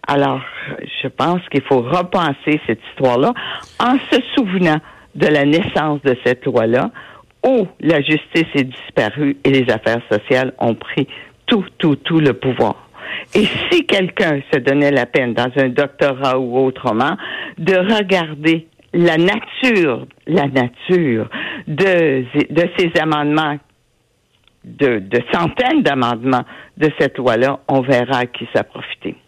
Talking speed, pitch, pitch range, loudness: 135 wpm, 145 Hz, 130-175 Hz, -16 LUFS